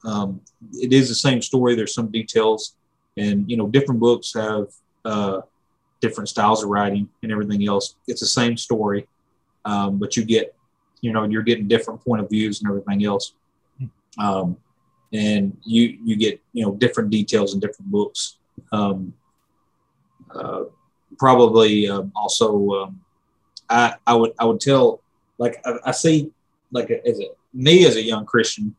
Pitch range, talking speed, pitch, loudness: 105-125 Hz, 165 wpm, 115 Hz, -20 LUFS